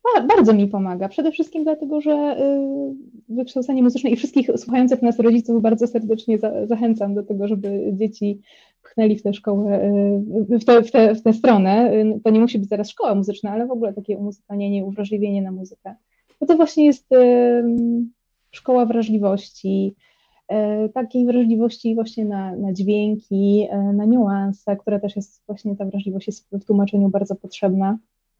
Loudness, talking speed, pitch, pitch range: -19 LUFS, 170 wpm, 215 Hz, 200-240 Hz